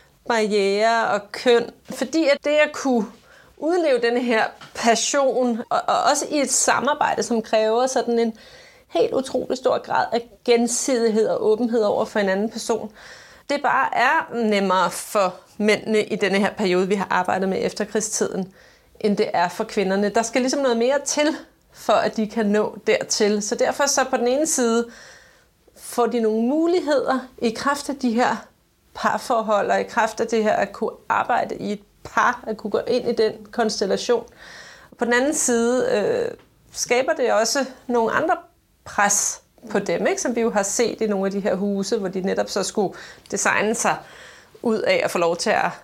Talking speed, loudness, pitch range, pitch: 185 wpm, -21 LUFS, 215-265 Hz, 230 Hz